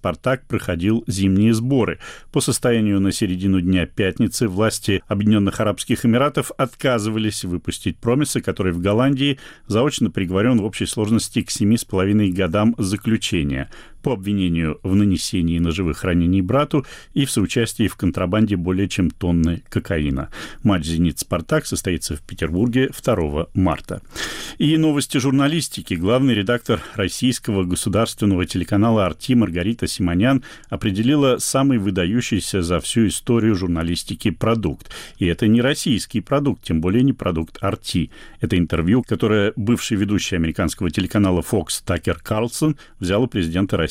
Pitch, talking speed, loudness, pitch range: 105 Hz, 130 wpm, -20 LUFS, 90-120 Hz